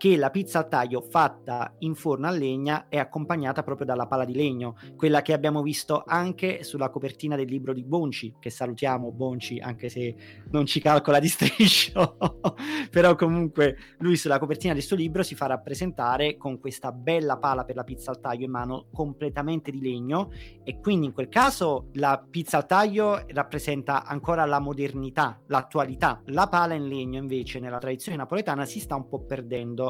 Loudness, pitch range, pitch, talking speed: -26 LUFS, 130-160 Hz, 145 Hz, 180 wpm